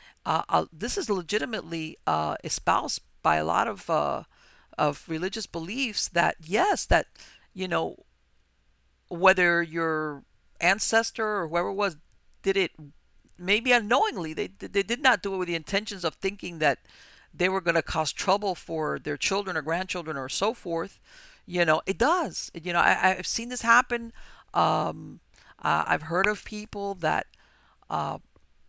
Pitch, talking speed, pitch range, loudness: 185 Hz, 155 wpm, 160-210 Hz, -26 LUFS